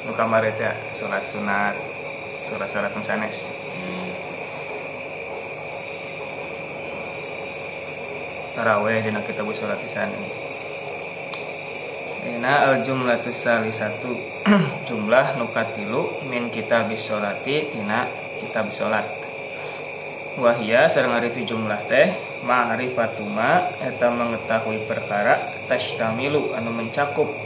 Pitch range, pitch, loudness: 110-130 Hz, 115 Hz, -23 LUFS